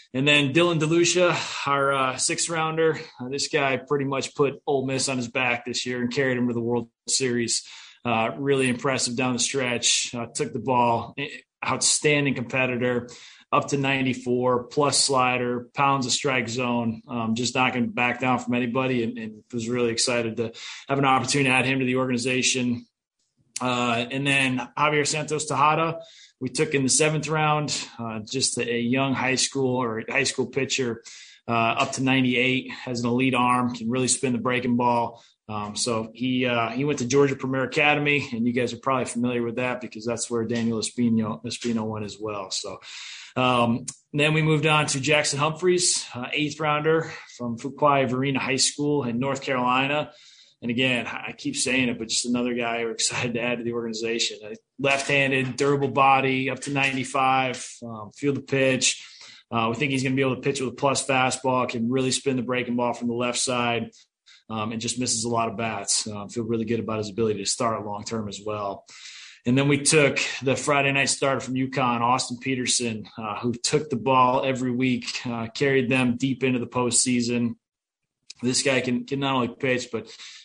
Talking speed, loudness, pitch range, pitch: 195 wpm, -24 LUFS, 120-135 Hz, 125 Hz